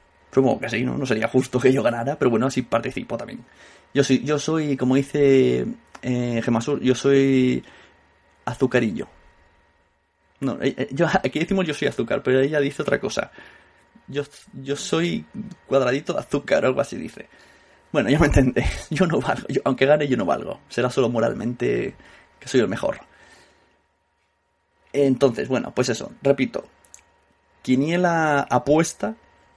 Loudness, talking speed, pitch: -22 LUFS, 155 wpm, 130 Hz